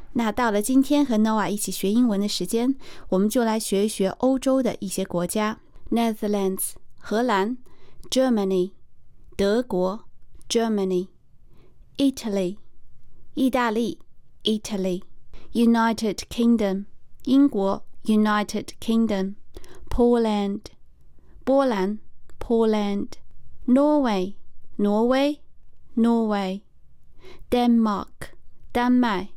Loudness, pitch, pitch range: -23 LUFS, 215 Hz, 195-240 Hz